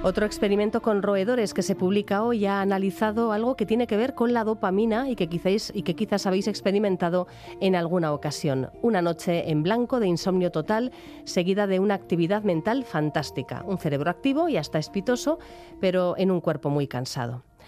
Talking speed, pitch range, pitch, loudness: 185 wpm, 170-220 Hz, 195 Hz, -25 LUFS